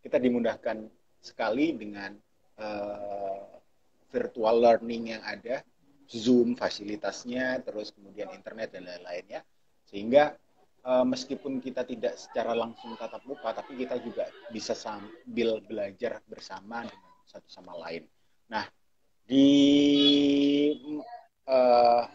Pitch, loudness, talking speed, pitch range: 120 Hz, -28 LUFS, 105 wpm, 110-135 Hz